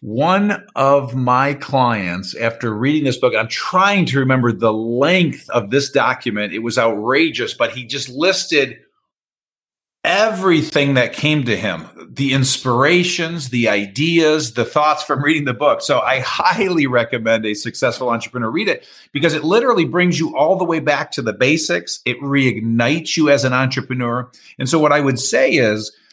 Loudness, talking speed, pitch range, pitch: -16 LUFS, 170 wpm, 120-160 Hz, 140 Hz